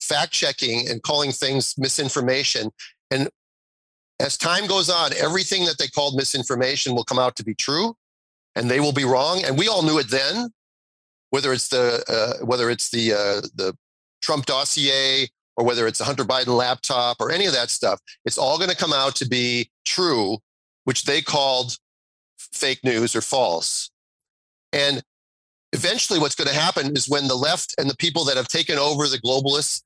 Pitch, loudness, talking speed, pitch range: 135 Hz, -21 LUFS, 180 wpm, 120-145 Hz